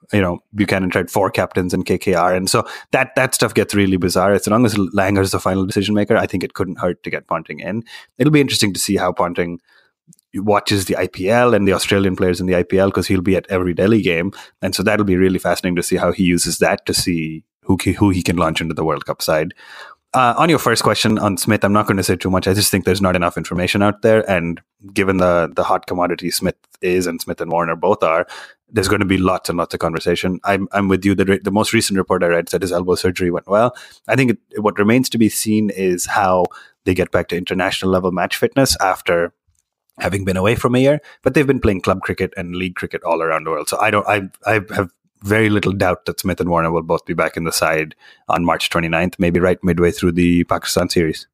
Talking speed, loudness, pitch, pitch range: 250 wpm, -17 LUFS, 95 Hz, 90-100 Hz